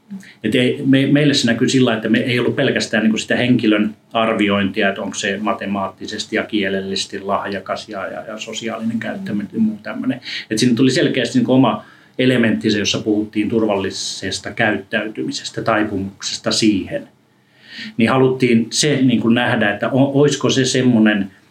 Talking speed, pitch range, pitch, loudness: 145 wpm, 105-130 Hz, 115 Hz, -17 LUFS